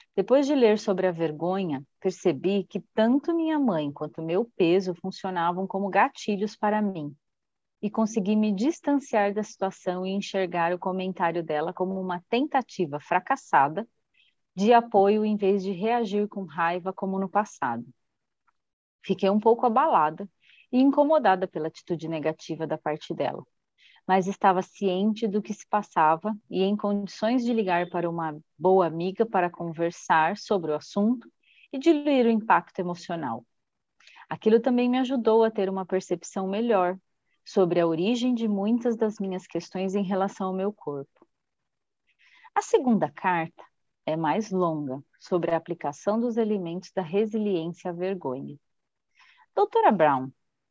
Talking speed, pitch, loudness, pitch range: 145 wpm, 195 Hz, -26 LUFS, 175-220 Hz